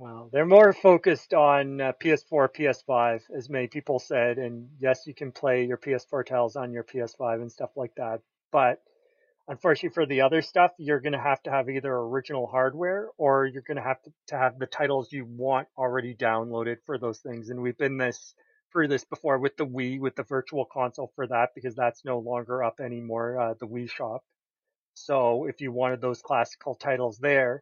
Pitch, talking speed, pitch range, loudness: 130 Hz, 200 wpm, 120-145 Hz, -26 LUFS